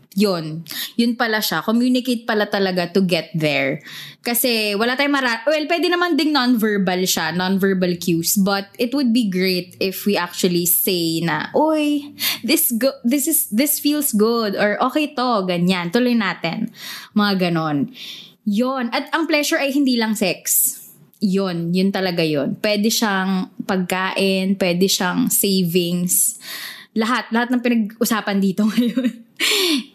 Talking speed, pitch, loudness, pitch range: 145 wpm, 215 Hz, -18 LUFS, 185-250 Hz